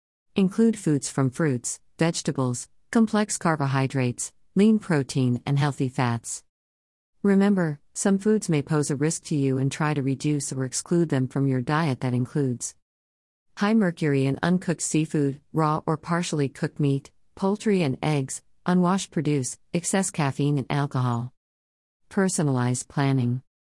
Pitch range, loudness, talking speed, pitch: 130-170 Hz, -25 LUFS, 135 wpm, 145 Hz